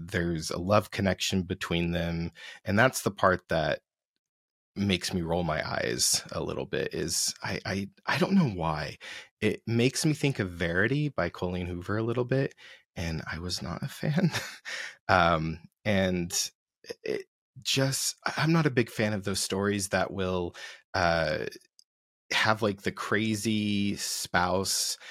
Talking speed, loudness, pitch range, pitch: 155 wpm, -29 LUFS, 90-115 Hz, 100 Hz